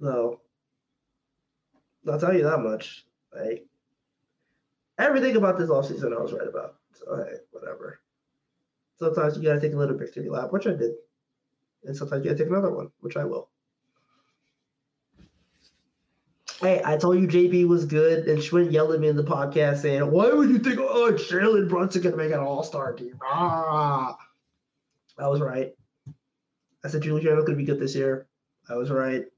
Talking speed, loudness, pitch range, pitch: 175 wpm, -24 LUFS, 140-180 Hz, 155 Hz